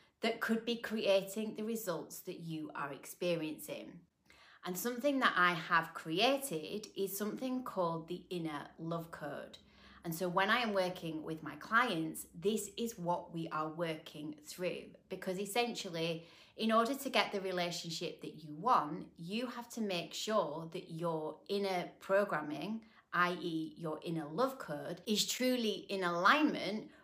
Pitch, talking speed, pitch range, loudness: 180 Hz, 150 wpm, 165-220 Hz, -37 LUFS